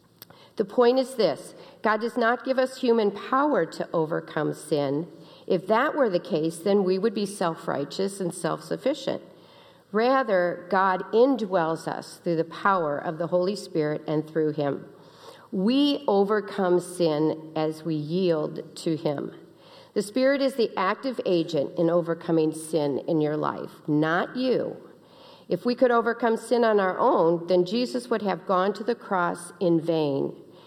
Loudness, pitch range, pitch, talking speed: -25 LUFS, 165-230 Hz, 185 Hz, 160 wpm